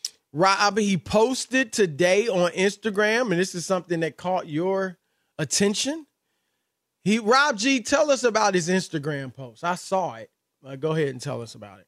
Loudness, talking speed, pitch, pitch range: -23 LUFS, 170 wpm, 190 Hz, 160-215 Hz